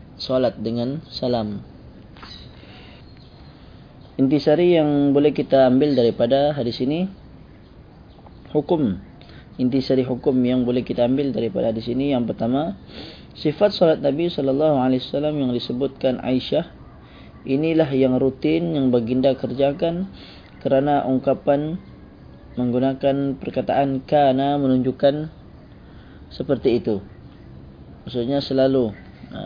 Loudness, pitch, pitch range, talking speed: -20 LUFS, 135 Hz, 125-145 Hz, 100 wpm